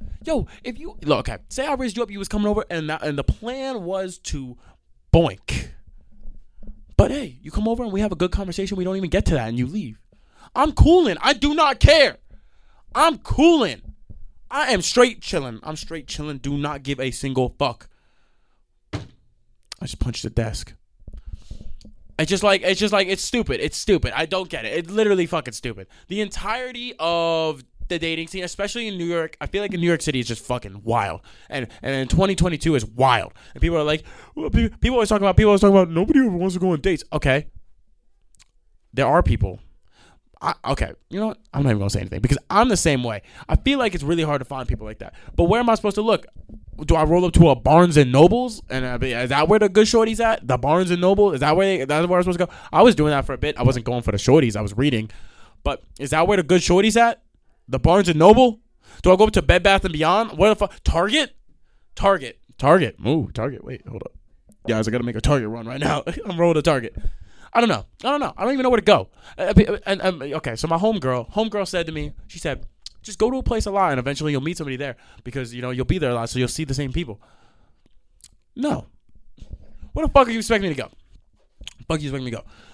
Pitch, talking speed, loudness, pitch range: 165 Hz, 245 wpm, -20 LUFS, 125-200 Hz